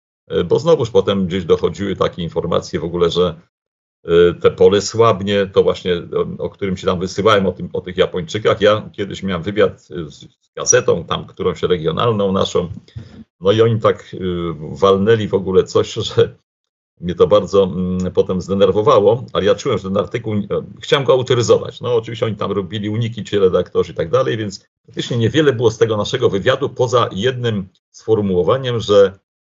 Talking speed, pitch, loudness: 165 wpm, 130 Hz, -16 LUFS